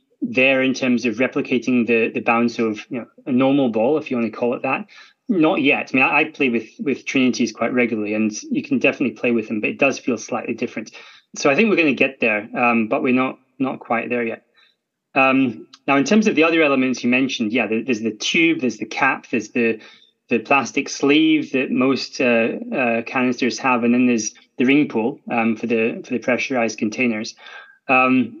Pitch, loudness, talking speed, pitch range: 125 Hz, -19 LUFS, 220 wpm, 115-135 Hz